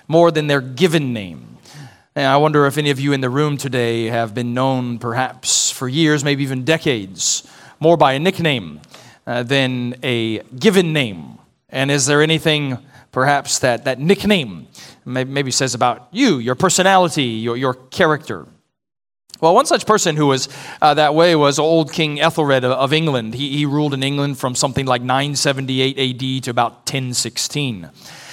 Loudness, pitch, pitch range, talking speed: -17 LUFS, 140 Hz, 125-150 Hz, 170 wpm